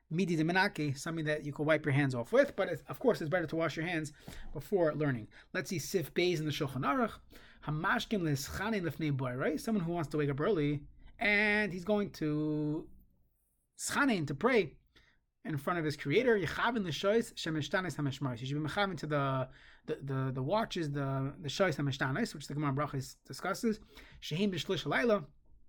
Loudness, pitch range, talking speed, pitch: -33 LUFS, 145-190 Hz, 165 wpm, 155 Hz